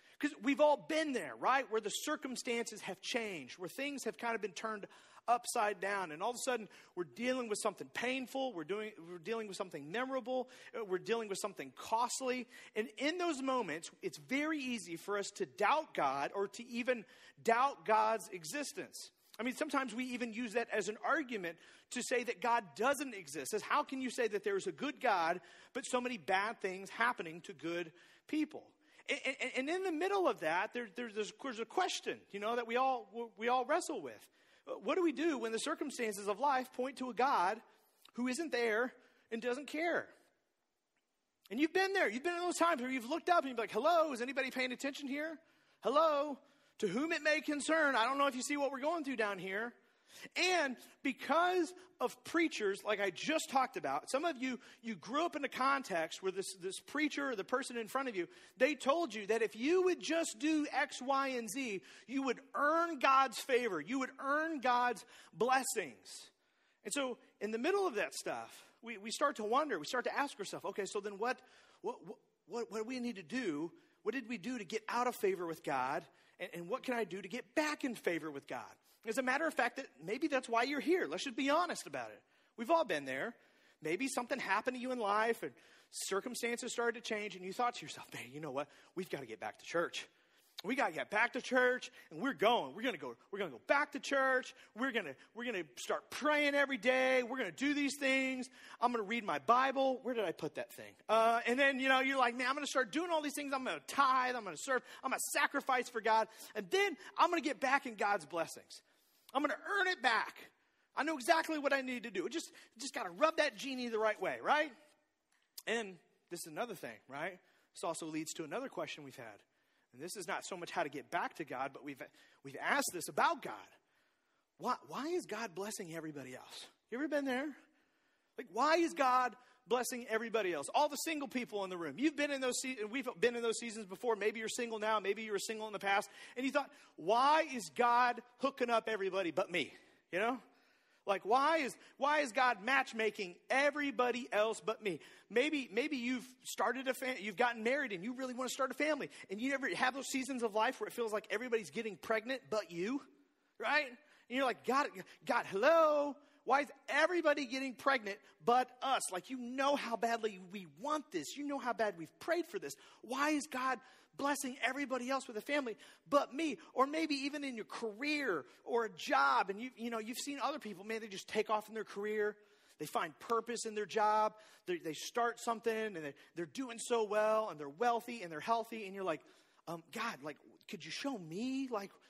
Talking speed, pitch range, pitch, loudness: 225 wpm, 220-285 Hz, 250 Hz, -37 LUFS